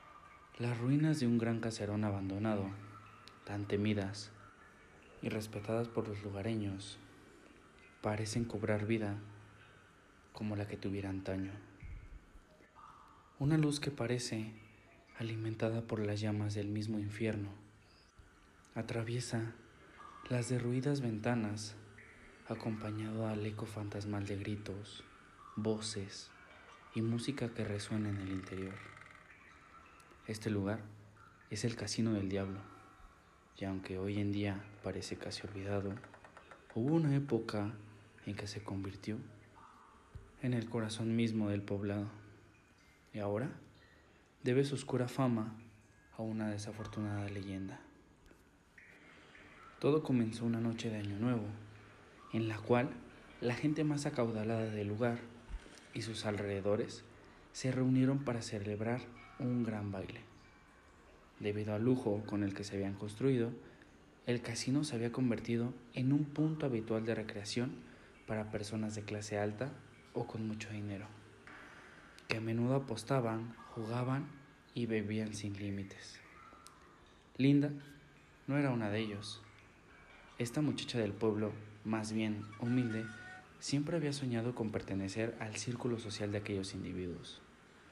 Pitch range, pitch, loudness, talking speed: 100-120 Hz, 110 Hz, -38 LUFS, 120 wpm